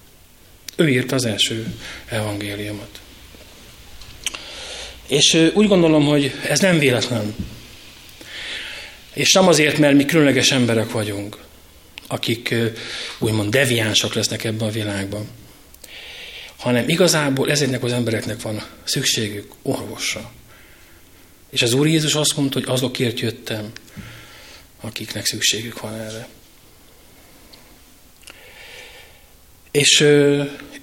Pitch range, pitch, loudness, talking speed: 105-140 Hz, 115 Hz, -18 LUFS, 95 wpm